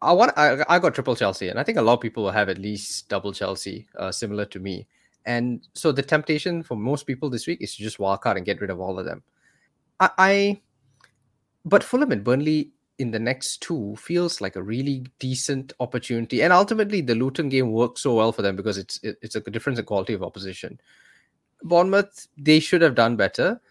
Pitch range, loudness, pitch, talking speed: 105-155 Hz, -23 LUFS, 120 Hz, 220 wpm